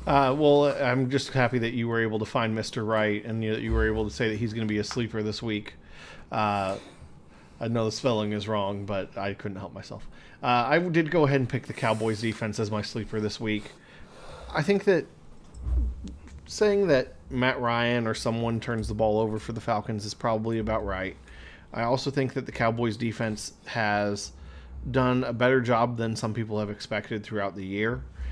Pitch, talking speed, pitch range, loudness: 110 Hz, 205 wpm, 105-120 Hz, -27 LUFS